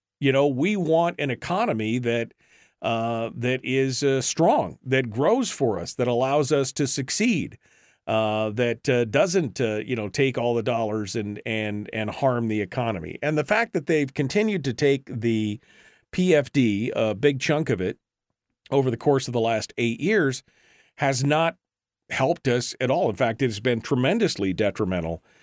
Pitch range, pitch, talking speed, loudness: 115-145 Hz, 130 Hz, 175 wpm, -24 LUFS